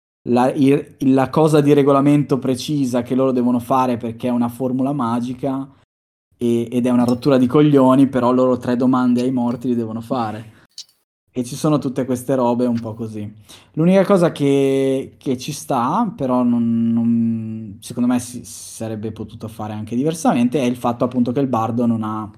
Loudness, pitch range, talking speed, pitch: -18 LUFS, 115-135 Hz, 180 wpm, 125 Hz